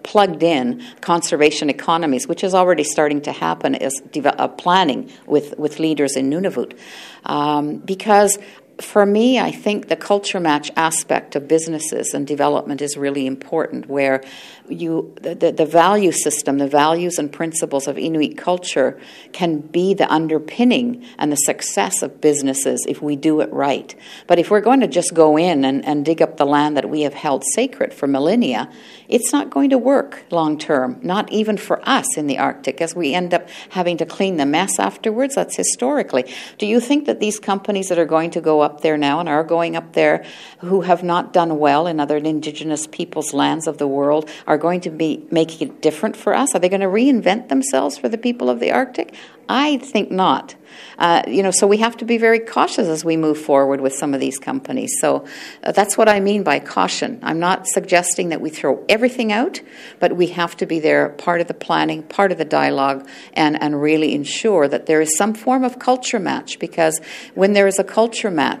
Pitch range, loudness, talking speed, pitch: 150-205 Hz, -18 LUFS, 205 wpm, 170 Hz